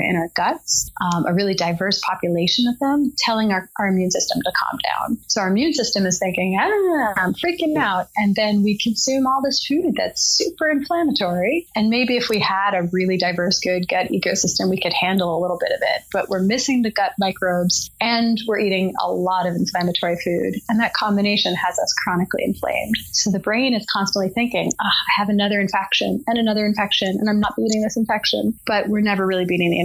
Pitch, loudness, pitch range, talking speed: 205 Hz, -19 LUFS, 185-230 Hz, 210 wpm